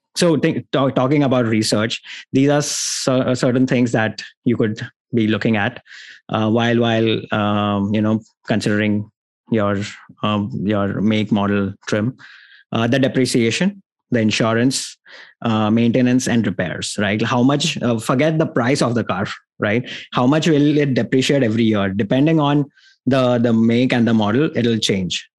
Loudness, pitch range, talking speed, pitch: -18 LUFS, 110-130 Hz, 160 wpm, 120 Hz